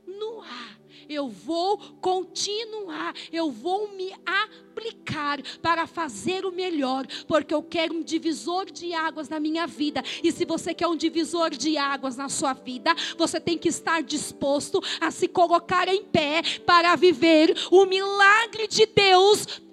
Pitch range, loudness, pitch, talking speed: 315-370 Hz, -24 LUFS, 335 Hz, 150 wpm